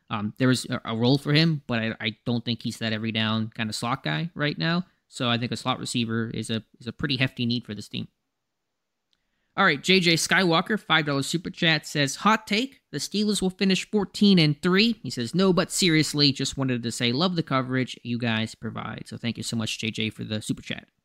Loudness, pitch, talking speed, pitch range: -24 LUFS, 135 Hz, 230 wpm, 115-170 Hz